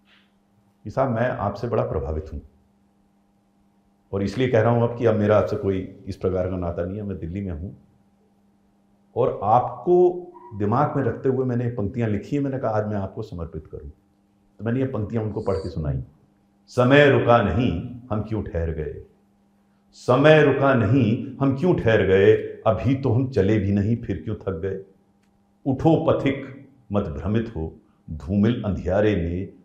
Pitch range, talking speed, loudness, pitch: 100-120 Hz, 170 wpm, -22 LUFS, 100 Hz